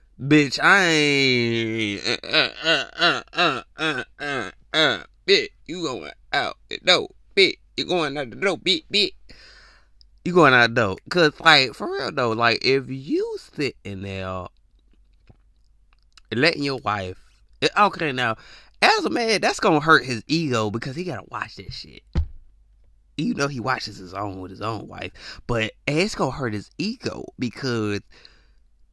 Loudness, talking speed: -21 LUFS, 165 wpm